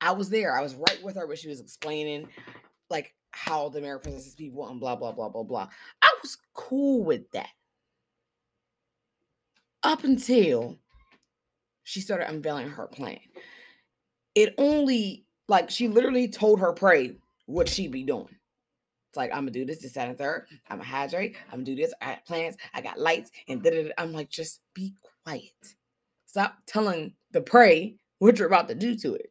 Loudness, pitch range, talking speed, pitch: -26 LUFS, 155-240 Hz, 180 wpm, 200 Hz